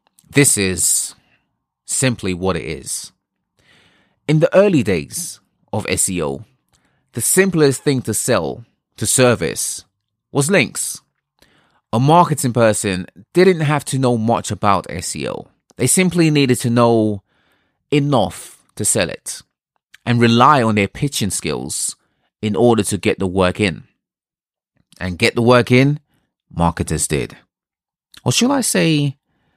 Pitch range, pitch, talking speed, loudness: 100-145 Hz, 120 Hz, 130 wpm, -16 LUFS